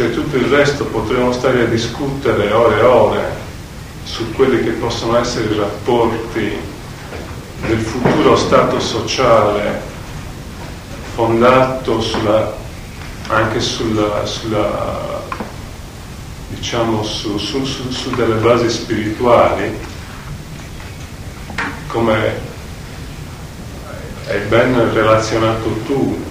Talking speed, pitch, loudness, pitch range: 90 wpm, 115 Hz, -15 LUFS, 110-120 Hz